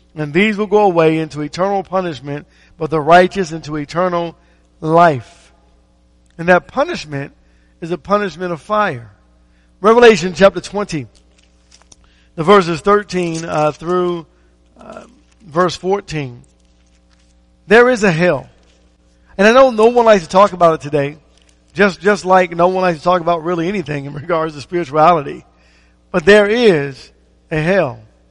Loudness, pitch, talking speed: -14 LUFS, 165 Hz, 145 wpm